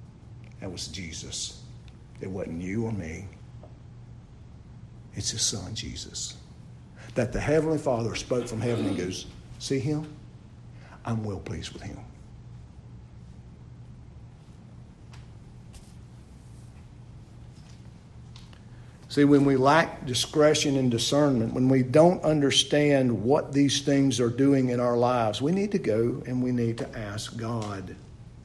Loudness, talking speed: -26 LUFS, 120 wpm